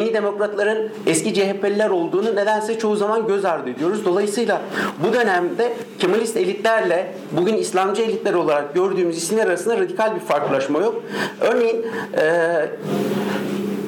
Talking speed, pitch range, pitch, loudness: 125 wpm, 195-225 Hz, 215 Hz, -20 LUFS